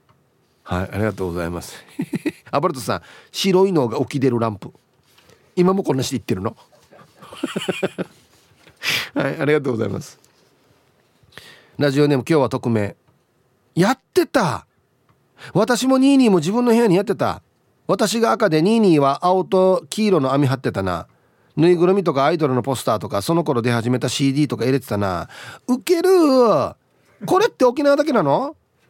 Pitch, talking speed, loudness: 145 Hz, 315 characters per minute, -19 LUFS